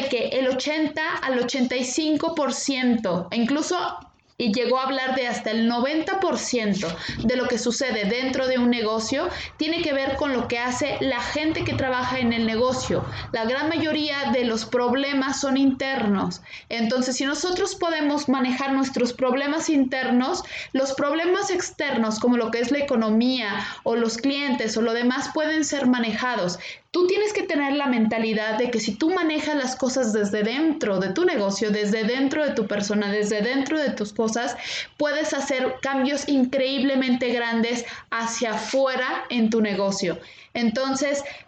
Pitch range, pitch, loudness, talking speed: 230-285 Hz, 255 Hz, -23 LUFS, 160 wpm